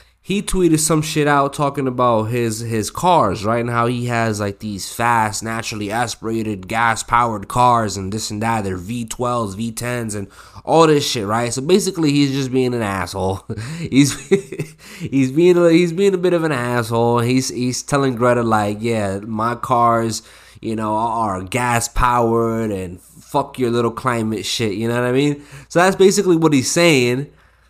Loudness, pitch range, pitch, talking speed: -18 LUFS, 110-140 Hz, 120 Hz, 180 wpm